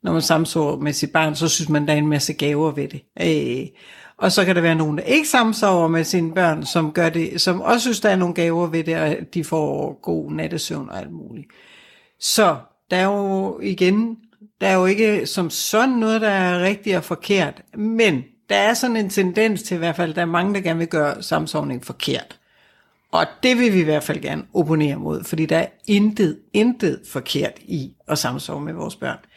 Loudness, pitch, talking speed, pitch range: -20 LUFS, 175 Hz, 220 wpm, 160-205 Hz